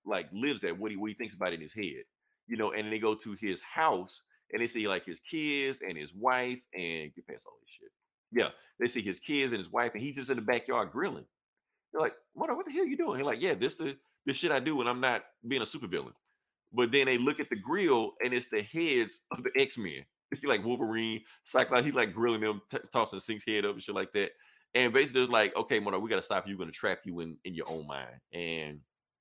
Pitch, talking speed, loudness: 120 Hz, 260 wpm, -32 LUFS